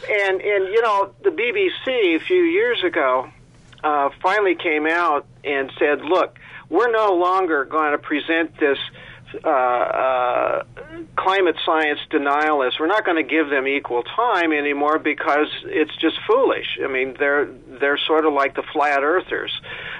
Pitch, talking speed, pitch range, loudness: 155 Hz, 155 wpm, 145-210 Hz, -20 LUFS